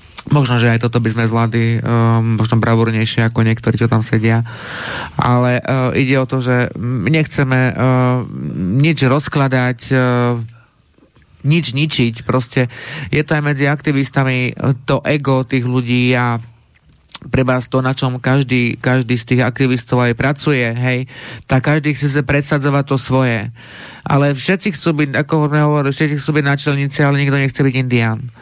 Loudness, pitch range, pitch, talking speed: -15 LUFS, 120-140 Hz, 130 Hz, 155 wpm